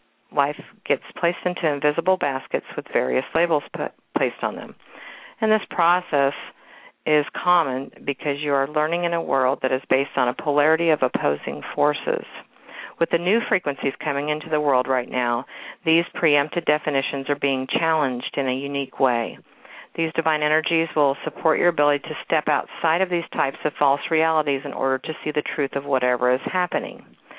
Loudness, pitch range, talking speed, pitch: -22 LUFS, 135-165 Hz, 175 wpm, 150 Hz